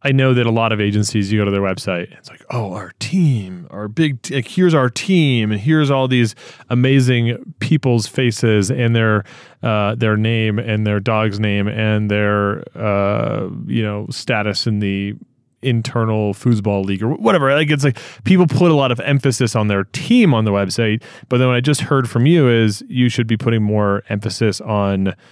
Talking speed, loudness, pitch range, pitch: 200 wpm, -17 LUFS, 105-130 Hz, 115 Hz